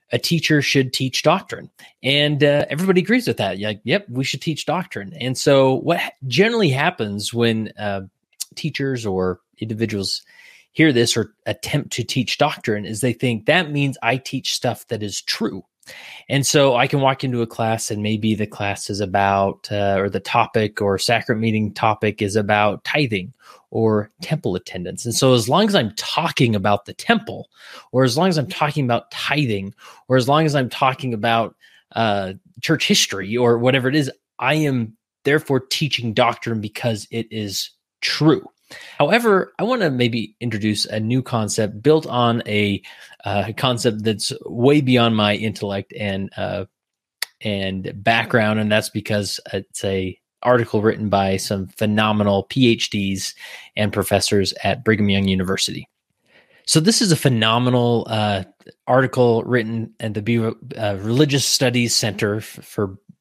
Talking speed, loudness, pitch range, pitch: 165 wpm, -19 LUFS, 105-135 Hz, 115 Hz